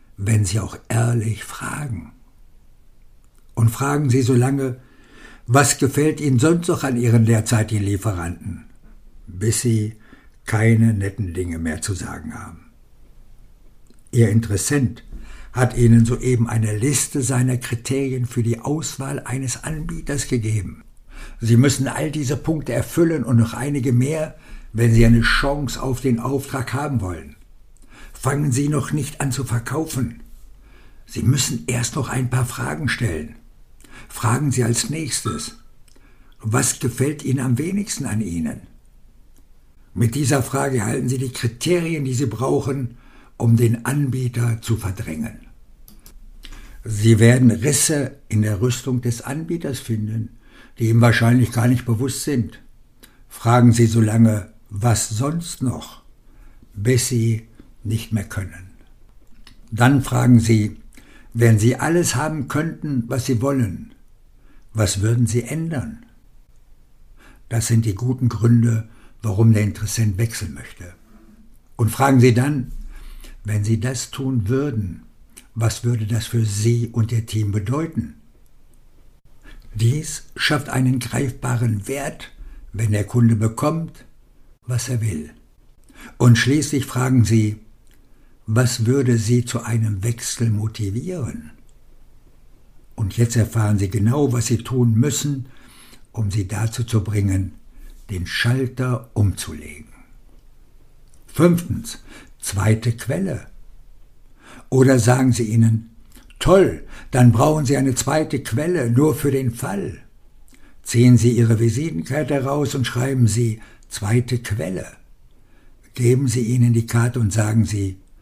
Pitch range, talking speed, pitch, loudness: 110-130 Hz, 125 wpm, 120 Hz, -20 LUFS